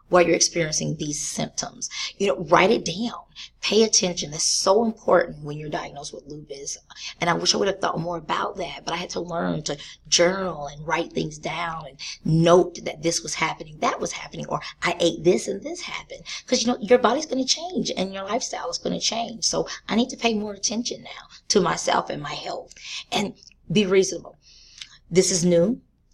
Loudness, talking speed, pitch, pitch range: -23 LUFS, 205 wpm, 180 Hz, 165-225 Hz